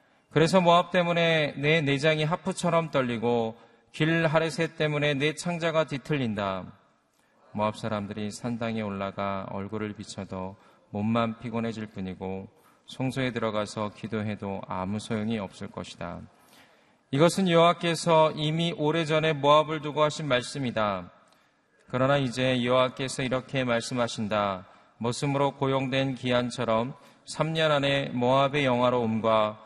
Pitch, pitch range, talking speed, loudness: 125 Hz, 110-155 Hz, 295 characters per minute, -27 LUFS